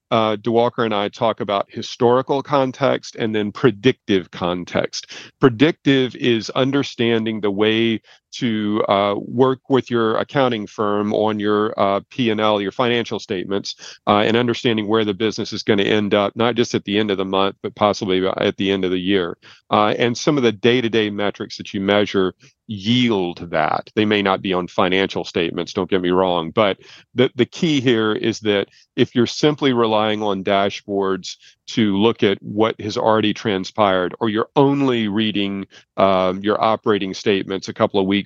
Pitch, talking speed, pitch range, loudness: 110 Hz, 175 wpm, 100-120 Hz, -19 LUFS